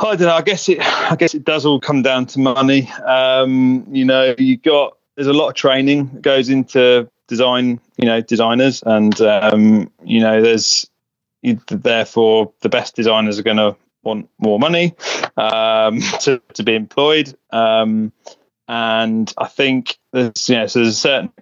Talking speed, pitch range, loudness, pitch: 175 wpm, 110-140 Hz, -15 LUFS, 125 Hz